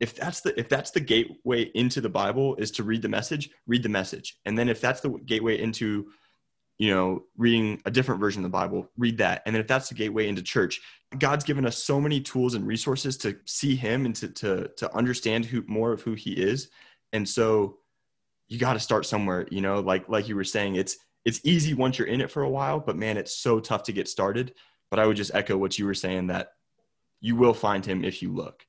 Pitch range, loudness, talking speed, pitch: 100-125 Hz, -27 LUFS, 240 wpm, 110 Hz